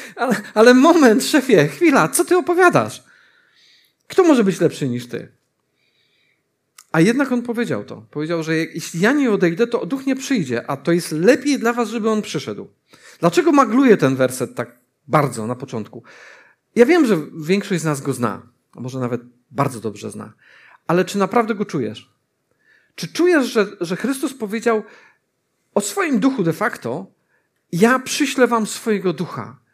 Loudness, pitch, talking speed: -18 LUFS, 205 Hz, 160 wpm